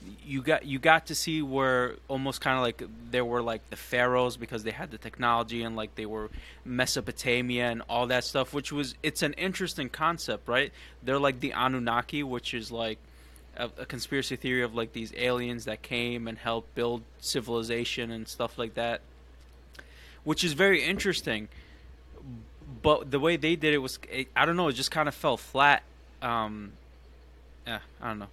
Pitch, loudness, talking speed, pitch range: 120 Hz, -29 LUFS, 185 wpm, 110-135 Hz